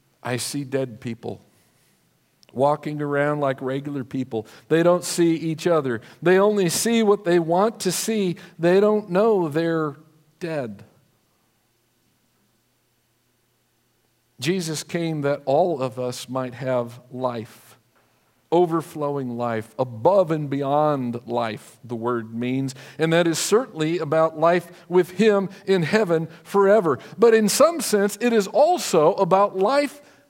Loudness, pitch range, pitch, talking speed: -22 LUFS, 125-180 Hz, 155 Hz, 130 wpm